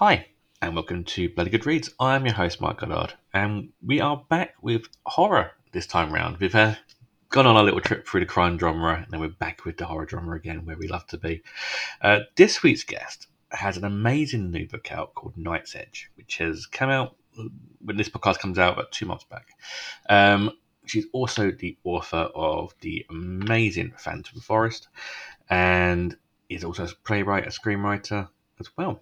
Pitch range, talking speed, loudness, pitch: 85-110 Hz, 190 wpm, -24 LUFS, 100 Hz